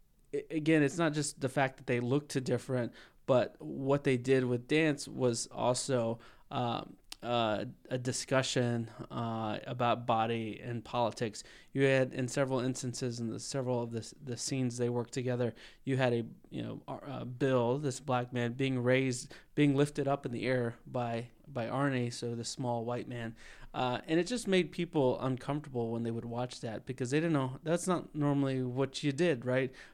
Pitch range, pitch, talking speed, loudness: 120-140 Hz, 130 Hz, 185 wpm, -34 LUFS